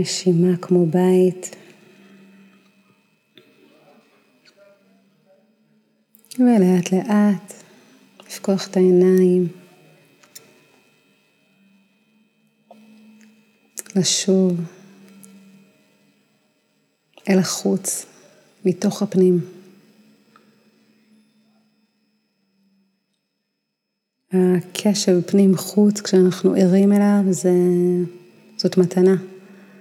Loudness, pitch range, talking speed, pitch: -18 LUFS, 185-215 Hz, 40 wpm, 195 Hz